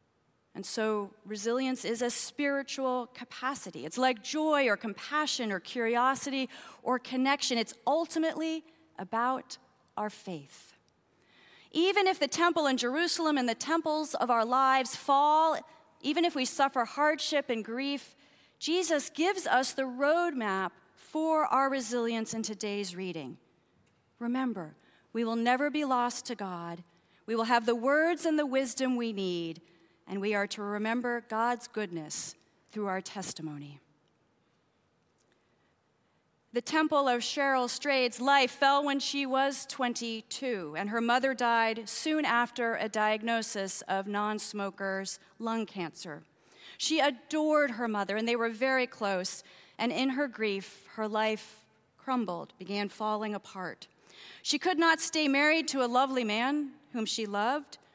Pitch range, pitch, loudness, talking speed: 215-280 Hz, 245 Hz, -30 LUFS, 140 wpm